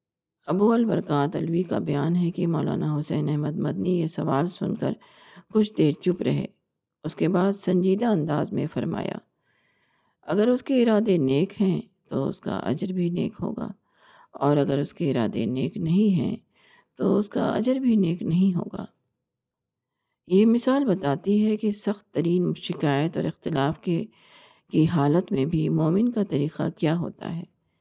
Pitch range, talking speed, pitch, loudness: 155-205 Hz, 165 wpm, 180 Hz, -25 LUFS